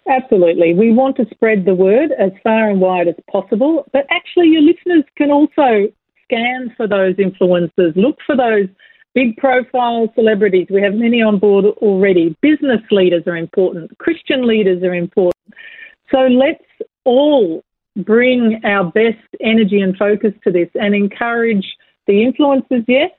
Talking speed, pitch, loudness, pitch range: 155 wpm, 225 Hz, -14 LUFS, 195-270 Hz